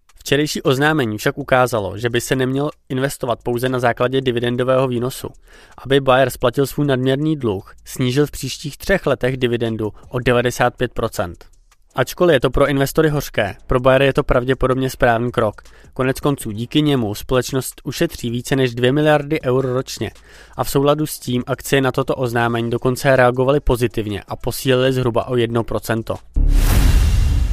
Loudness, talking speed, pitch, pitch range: -18 LUFS, 155 wpm, 130 Hz, 120-140 Hz